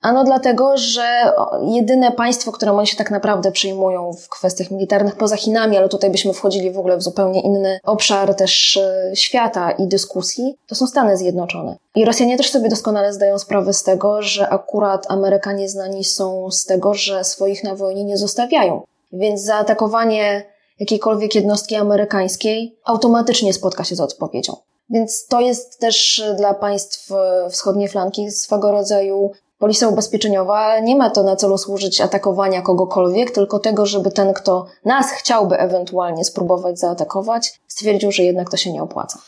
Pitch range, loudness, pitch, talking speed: 195-220 Hz, -16 LUFS, 200 Hz, 155 wpm